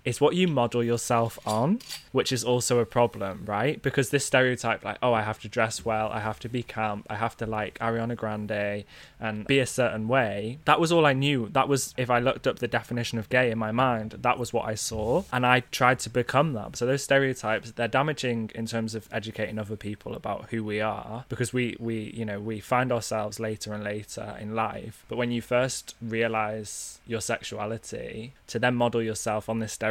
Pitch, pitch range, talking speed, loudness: 115 Hz, 110-125 Hz, 220 wpm, -27 LUFS